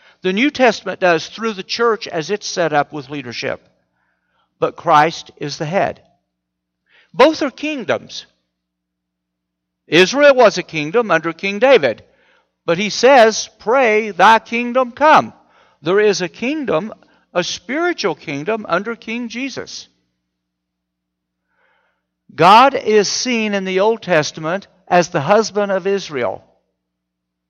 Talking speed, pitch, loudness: 125 wpm, 185 Hz, -15 LUFS